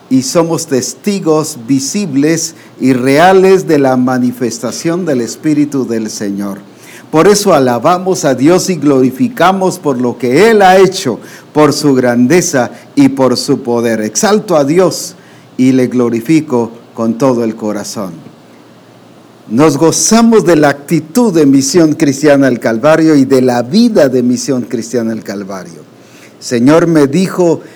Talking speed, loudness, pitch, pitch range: 140 wpm, -10 LUFS, 140 Hz, 120-170 Hz